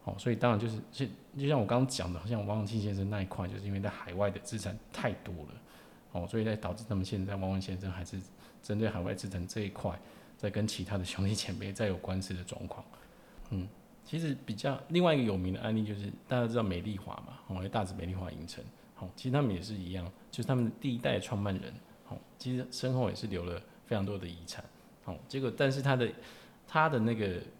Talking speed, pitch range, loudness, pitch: 340 characters per minute, 95-120 Hz, -35 LUFS, 105 Hz